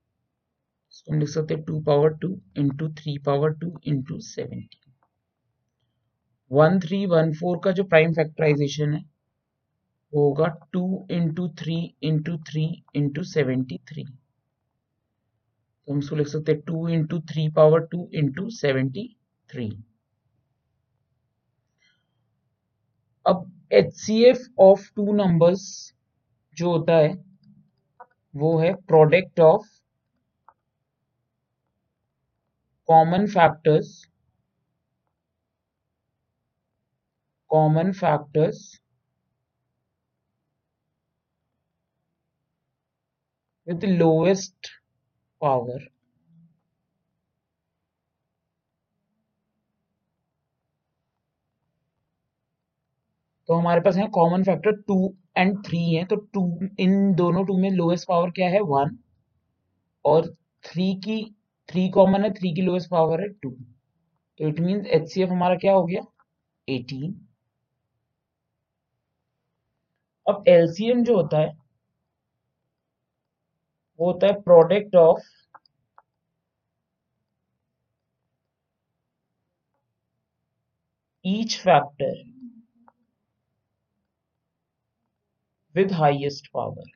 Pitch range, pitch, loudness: 140-185 Hz, 160 Hz, -22 LUFS